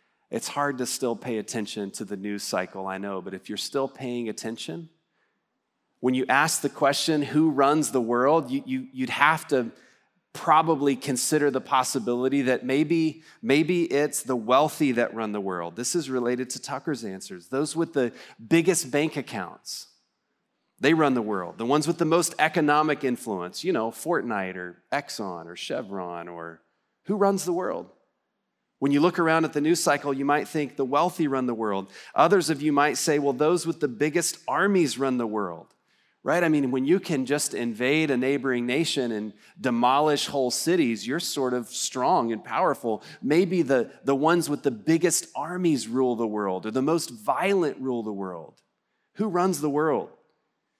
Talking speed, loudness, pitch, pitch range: 180 wpm, -25 LUFS, 140 Hz, 120-160 Hz